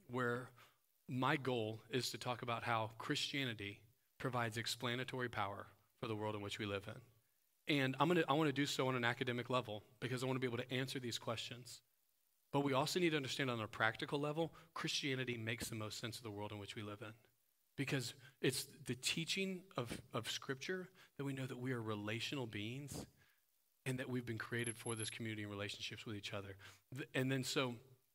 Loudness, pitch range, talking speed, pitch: -42 LUFS, 110-135 Hz, 205 wpm, 125 Hz